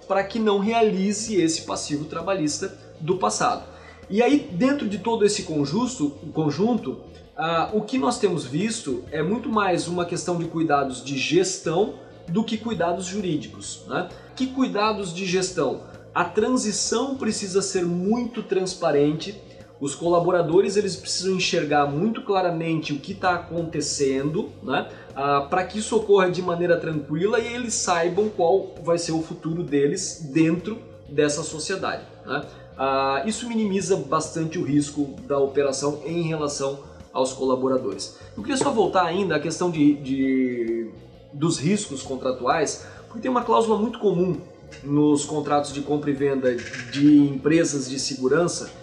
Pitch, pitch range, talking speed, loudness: 170 Hz, 145-205 Hz, 145 wpm, -23 LUFS